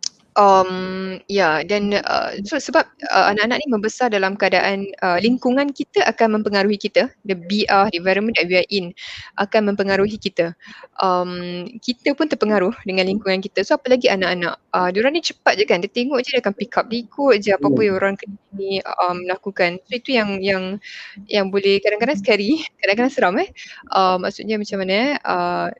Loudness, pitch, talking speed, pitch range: -19 LUFS, 200 Hz, 190 wpm, 190-230 Hz